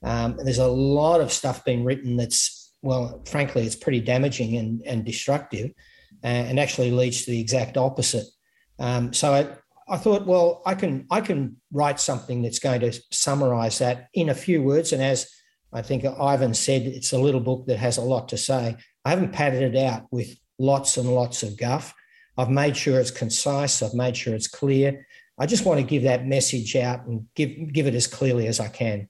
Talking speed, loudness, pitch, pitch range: 210 wpm, -23 LUFS, 130 Hz, 120-140 Hz